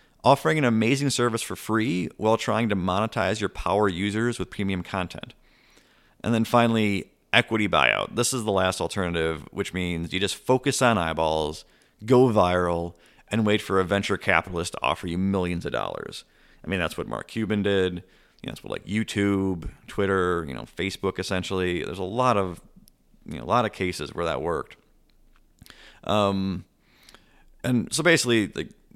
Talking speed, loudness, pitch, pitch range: 170 wpm, -25 LUFS, 100 Hz, 90-110 Hz